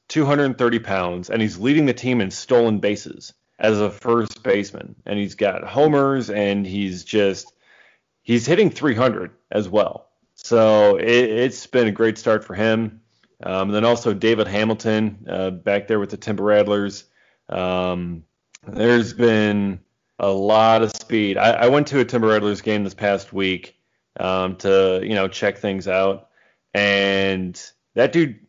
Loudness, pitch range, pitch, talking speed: -19 LUFS, 100-115 Hz, 105 Hz, 160 wpm